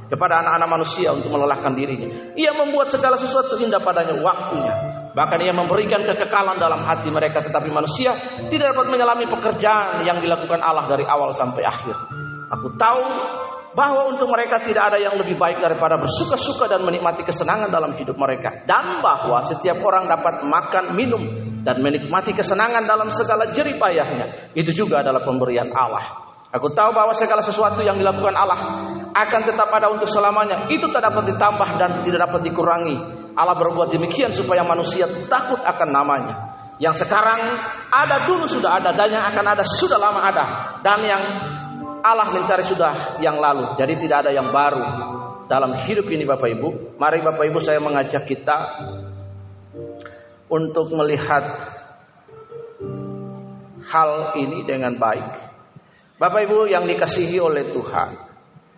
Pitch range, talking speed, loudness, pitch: 145-210 Hz, 150 wpm, -19 LUFS, 170 Hz